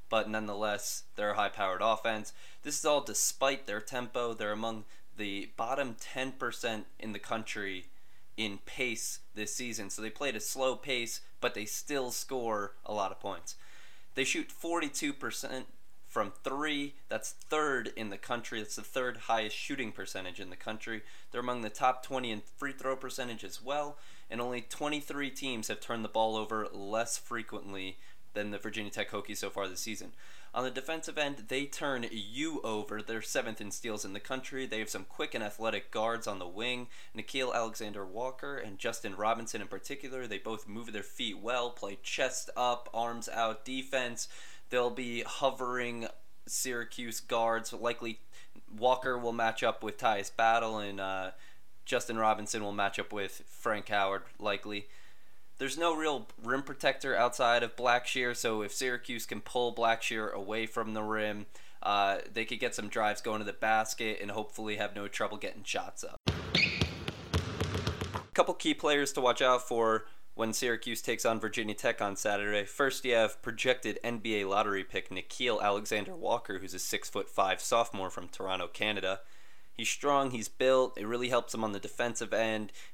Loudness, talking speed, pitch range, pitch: -34 LUFS, 175 wpm, 105-125 Hz, 115 Hz